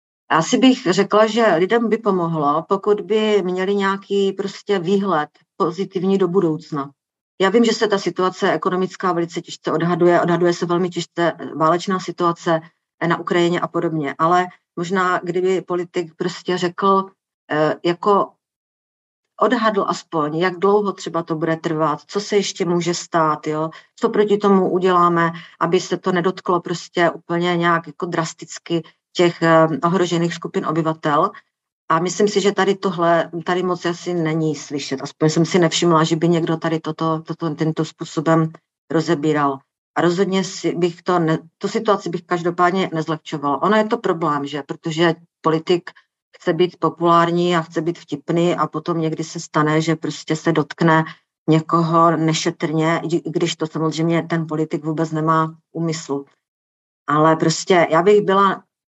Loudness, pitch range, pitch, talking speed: -19 LUFS, 160-185 Hz, 170 Hz, 150 wpm